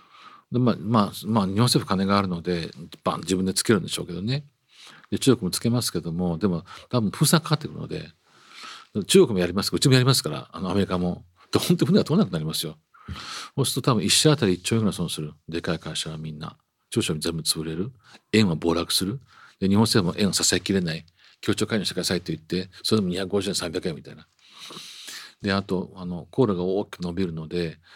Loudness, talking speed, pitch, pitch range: -24 LUFS, 410 characters per minute, 100 Hz, 90-130 Hz